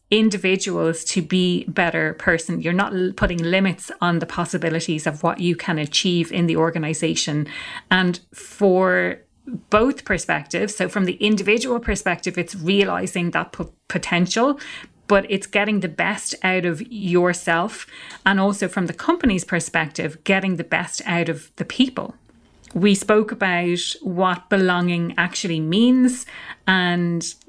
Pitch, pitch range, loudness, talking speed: 185 Hz, 170-205 Hz, -20 LUFS, 140 wpm